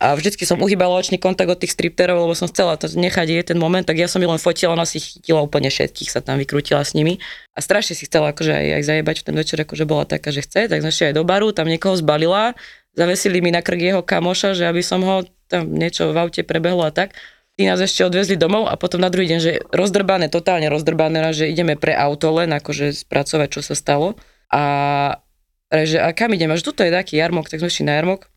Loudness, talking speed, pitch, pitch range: -18 LUFS, 240 wpm, 170 Hz, 155-180 Hz